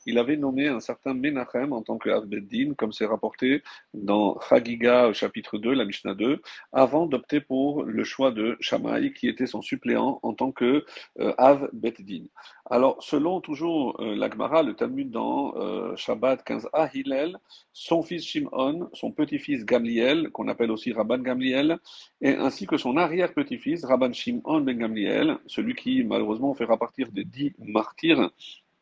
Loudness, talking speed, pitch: -26 LUFS, 155 wpm, 155 Hz